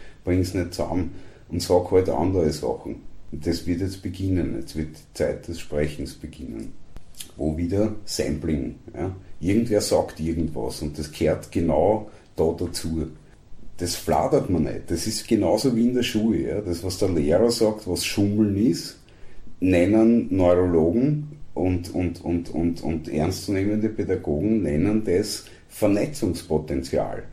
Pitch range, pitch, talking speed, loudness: 85-105 Hz, 90 Hz, 145 wpm, -24 LUFS